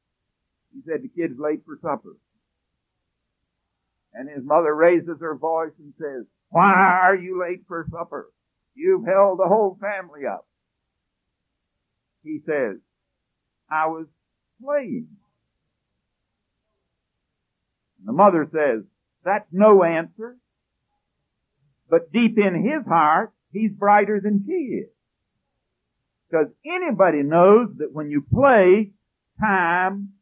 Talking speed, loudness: 115 wpm, -20 LUFS